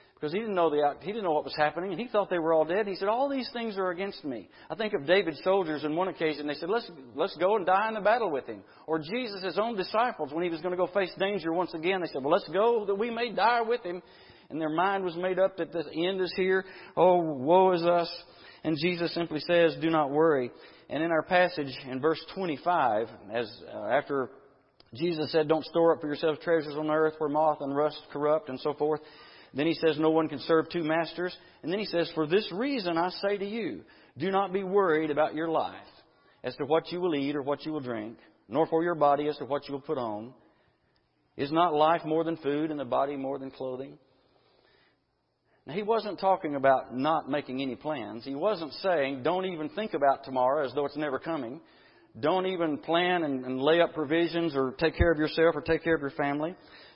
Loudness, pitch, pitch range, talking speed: -29 LUFS, 160 Hz, 150-180 Hz, 235 wpm